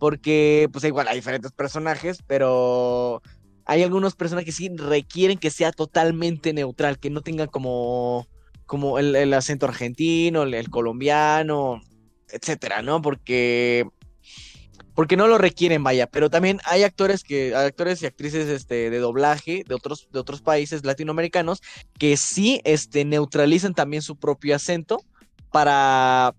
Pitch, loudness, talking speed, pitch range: 150 Hz, -22 LUFS, 145 wpm, 130-165 Hz